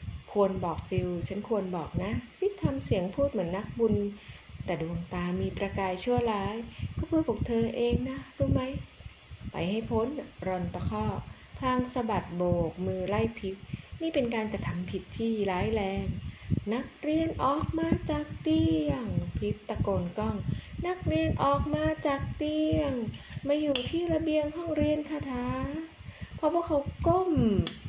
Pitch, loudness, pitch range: 225 Hz, -31 LUFS, 185-300 Hz